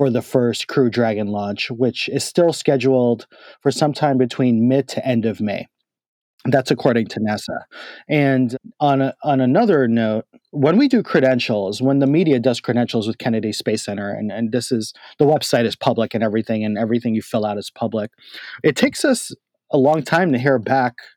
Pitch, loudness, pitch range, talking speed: 125 Hz, -19 LUFS, 110-135 Hz, 190 wpm